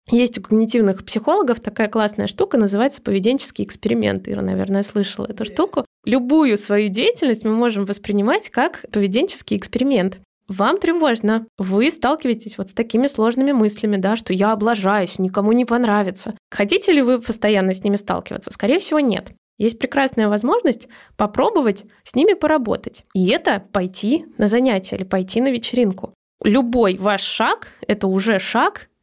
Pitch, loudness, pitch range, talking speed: 220 Hz, -19 LUFS, 200-255 Hz, 150 wpm